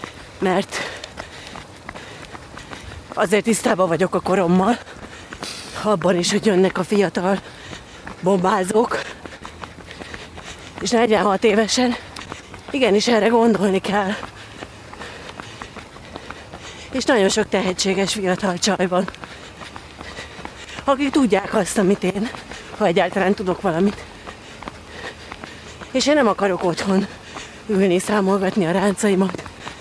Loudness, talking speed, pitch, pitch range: -19 LUFS, 90 wpm, 195 Hz, 185-215 Hz